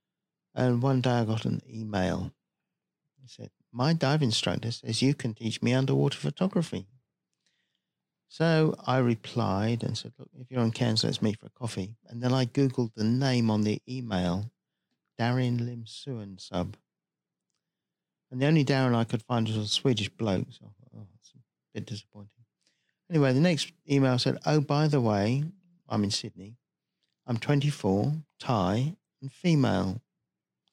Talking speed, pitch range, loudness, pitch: 155 wpm, 110-140 Hz, -28 LUFS, 125 Hz